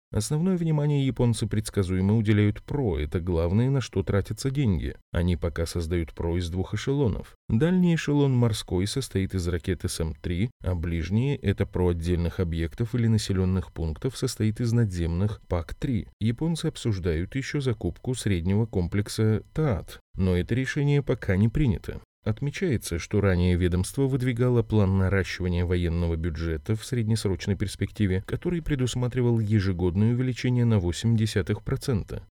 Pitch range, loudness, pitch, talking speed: 90-125 Hz, -26 LUFS, 105 Hz, 130 wpm